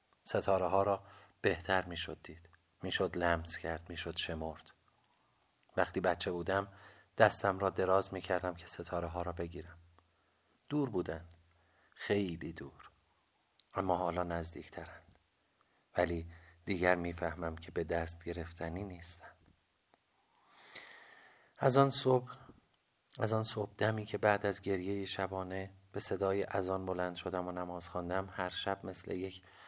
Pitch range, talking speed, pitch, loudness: 85-100 Hz, 135 wpm, 90 Hz, -36 LUFS